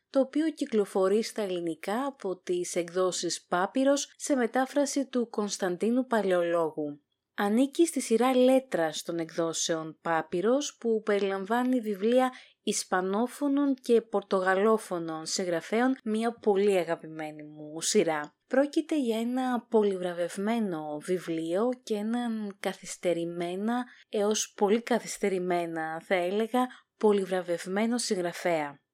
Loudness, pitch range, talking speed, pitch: -29 LUFS, 175-245 Hz, 100 wpm, 205 Hz